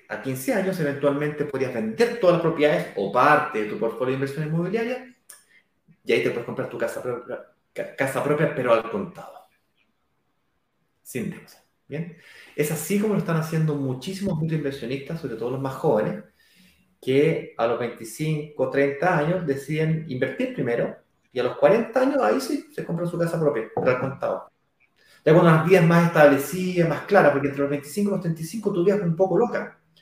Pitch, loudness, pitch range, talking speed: 155 Hz, -23 LUFS, 140-190 Hz, 180 wpm